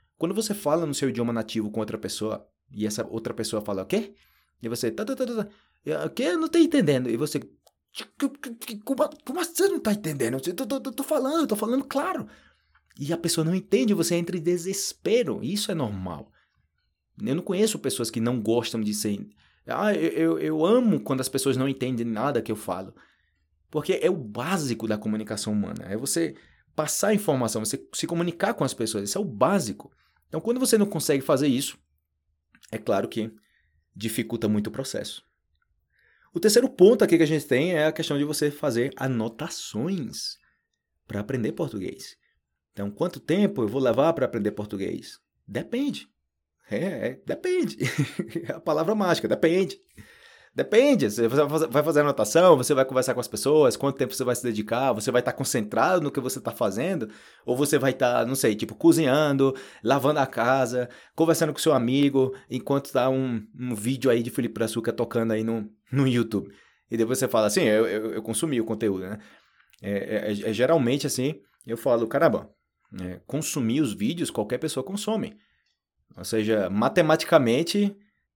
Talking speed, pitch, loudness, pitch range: 180 wpm, 135 Hz, -25 LUFS, 115-180 Hz